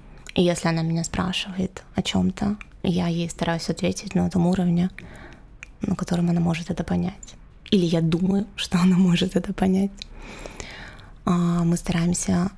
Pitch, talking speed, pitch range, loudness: 180 Hz, 150 wpm, 175-190 Hz, -23 LUFS